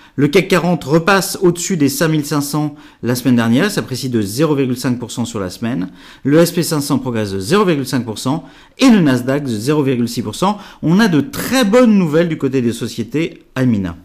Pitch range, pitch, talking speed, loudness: 120-170 Hz, 140 Hz, 160 wpm, -15 LUFS